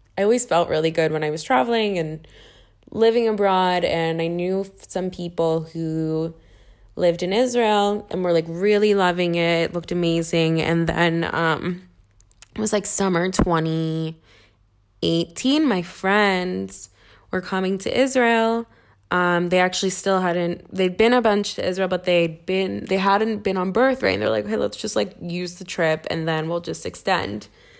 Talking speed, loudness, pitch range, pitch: 175 wpm, -21 LUFS, 165-195 Hz, 175 Hz